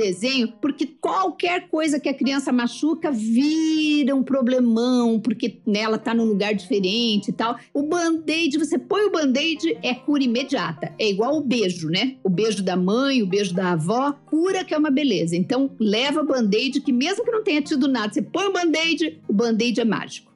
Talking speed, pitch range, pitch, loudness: 190 wpm, 225-310 Hz, 260 Hz, -21 LUFS